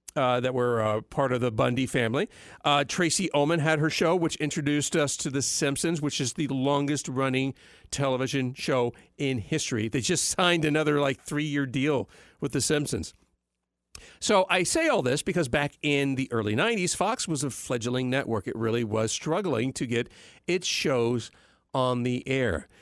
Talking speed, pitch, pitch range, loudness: 180 wpm, 140 Hz, 125-155 Hz, -27 LUFS